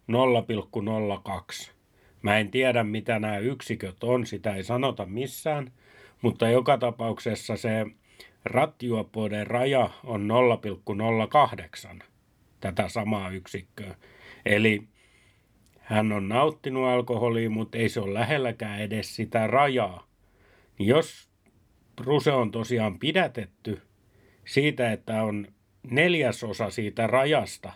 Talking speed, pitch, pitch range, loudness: 100 wpm, 110 Hz, 105-125 Hz, -26 LUFS